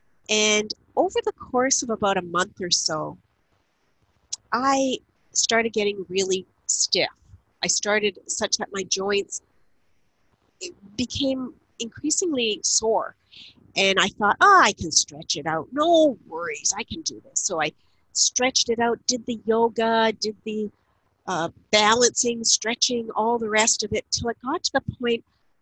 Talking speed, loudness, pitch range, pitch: 150 wpm, -22 LUFS, 205-250 Hz, 225 Hz